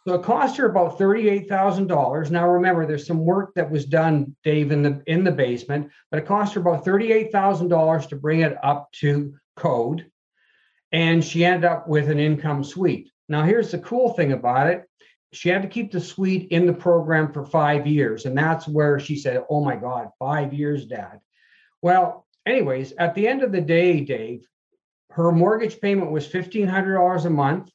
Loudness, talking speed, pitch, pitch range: -21 LUFS, 200 wpm, 170 Hz, 150-185 Hz